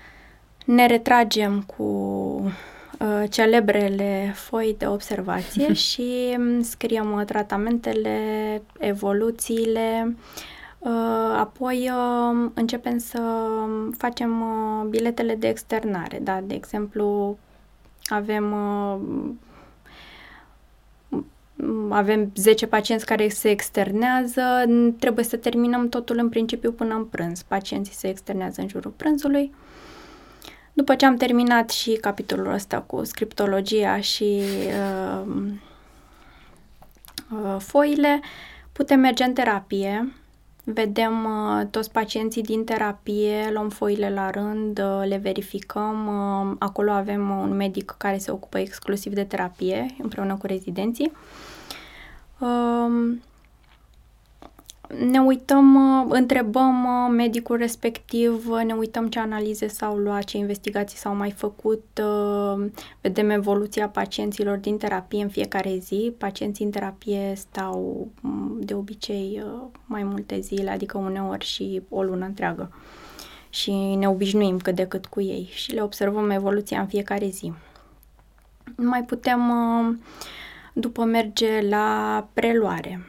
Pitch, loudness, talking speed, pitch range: 215 Hz, -23 LUFS, 110 wpm, 200-235 Hz